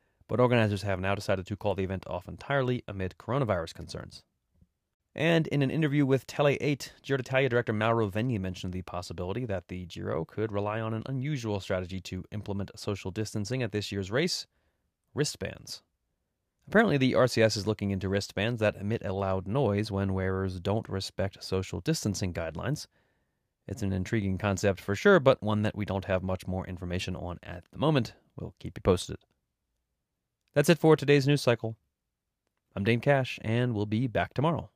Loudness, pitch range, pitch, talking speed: -29 LUFS, 95-125 Hz, 105 Hz, 175 wpm